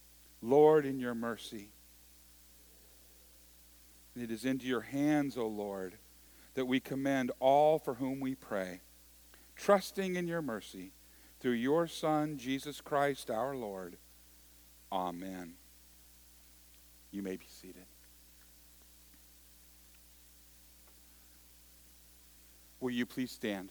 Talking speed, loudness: 105 wpm, -34 LUFS